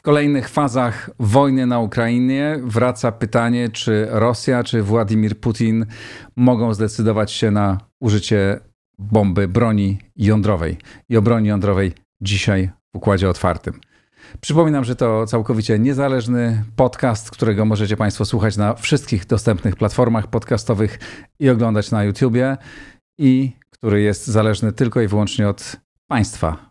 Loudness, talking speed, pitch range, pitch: -18 LUFS, 130 wpm, 105-125 Hz, 115 Hz